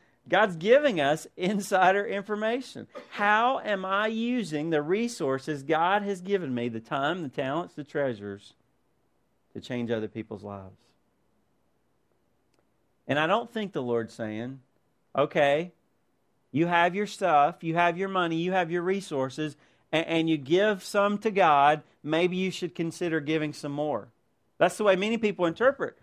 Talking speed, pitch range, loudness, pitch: 150 wpm, 140-200 Hz, -27 LUFS, 165 Hz